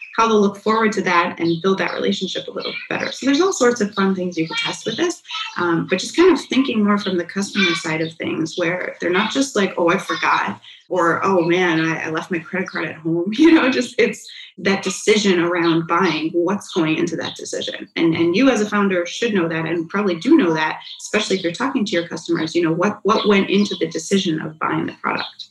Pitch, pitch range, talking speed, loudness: 190 Hz, 170-225 Hz, 240 wpm, -19 LUFS